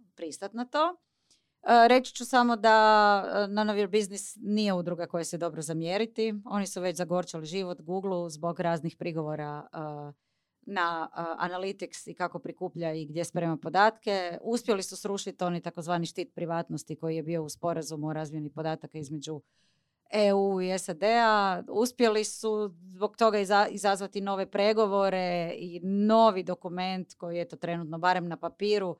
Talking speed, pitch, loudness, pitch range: 145 wpm, 185 Hz, -29 LUFS, 170-205 Hz